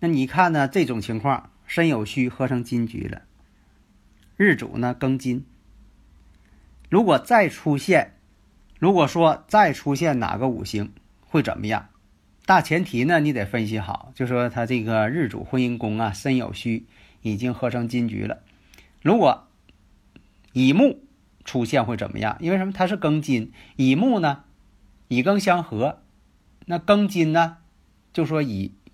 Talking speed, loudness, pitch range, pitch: 210 characters per minute, -22 LUFS, 105-160 Hz, 125 Hz